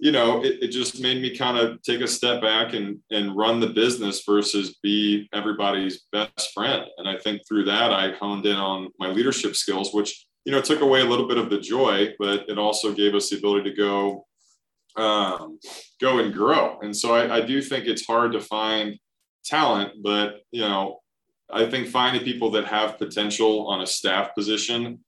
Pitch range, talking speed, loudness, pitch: 100-115 Hz, 200 wpm, -23 LUFS, 105 Hz